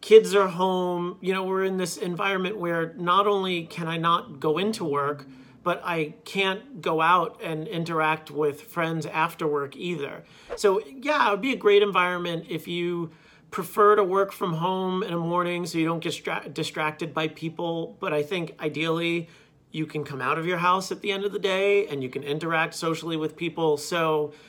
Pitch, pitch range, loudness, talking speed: 170 Hz, 155-190 Hz, -25 LUFS, 200 wpm